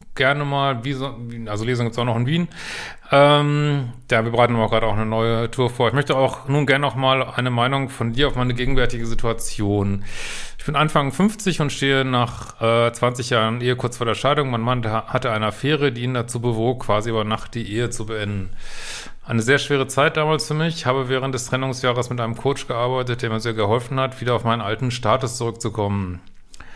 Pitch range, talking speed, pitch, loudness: 115-135 Hz, 210 wpm, 125 Hz, -21 LUFS